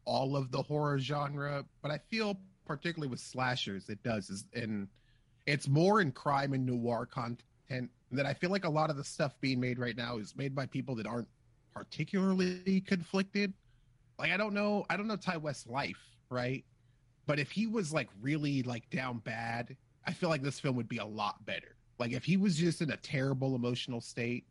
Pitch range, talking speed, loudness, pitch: 120-155 Hz, 205 wpm, -35 LUFS, 135 Hz